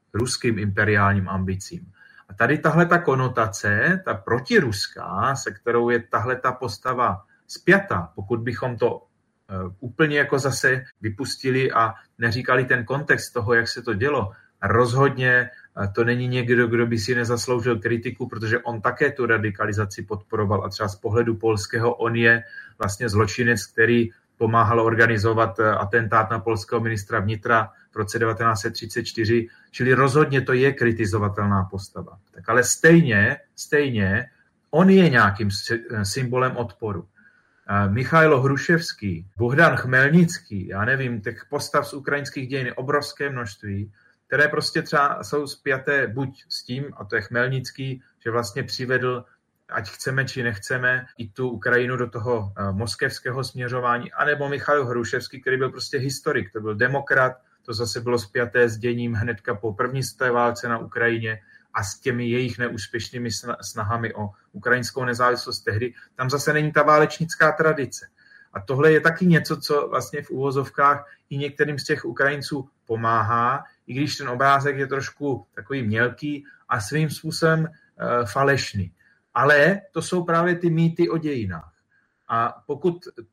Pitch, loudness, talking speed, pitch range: 125 Hz, -22 LUFS, 145 wpm, 115-140 Hz